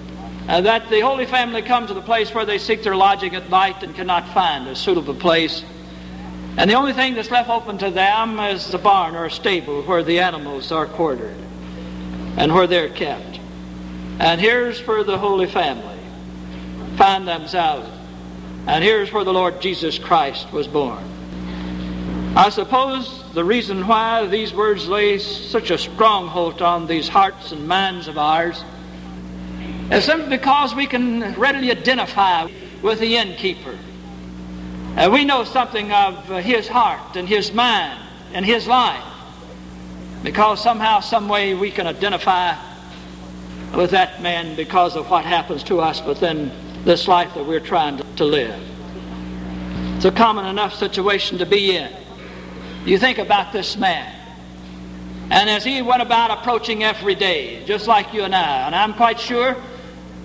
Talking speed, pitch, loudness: 155 wpm, 185 Hz, -18 LUFS